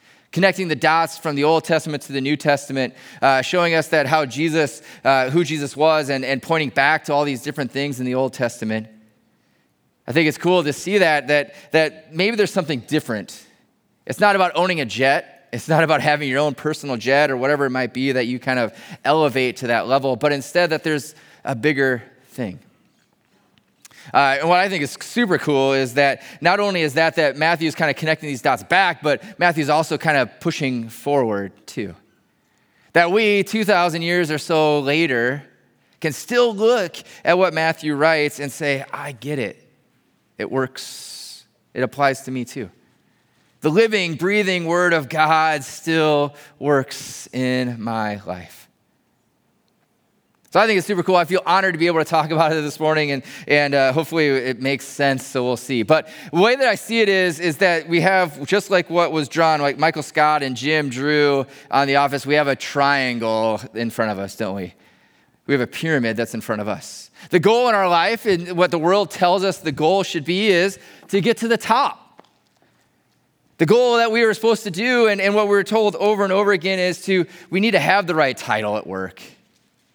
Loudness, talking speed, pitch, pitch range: -19 LUFS, 205 wpm, 155 Hz, 135-175 Hz